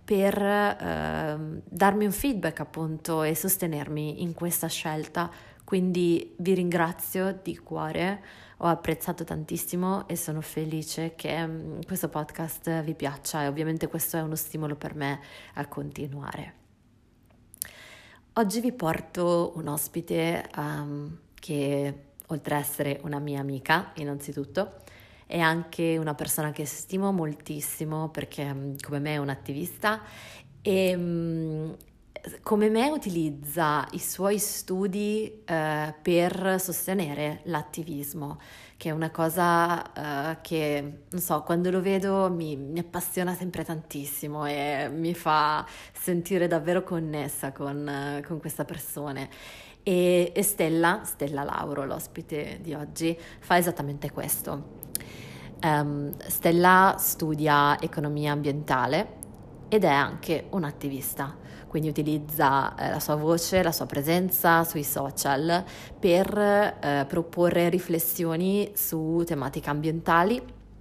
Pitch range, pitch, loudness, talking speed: 145-175 Hz, 160 Hz, -28 LUFS, 120 wpm